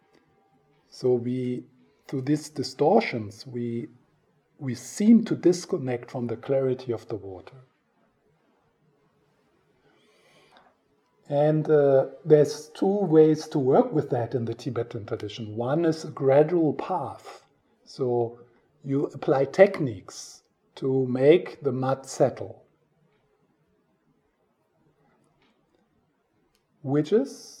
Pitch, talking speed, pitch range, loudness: 135 Hz, 100 wpm, 120-150 Hz, -25 LUFS